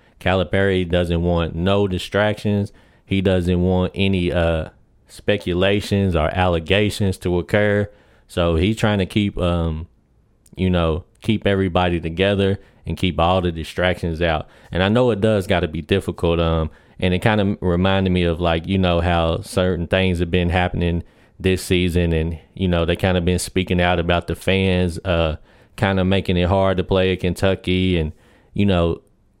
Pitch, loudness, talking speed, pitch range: 90 Hz, -20 LUFS, 175 wpm, 85-100 Hz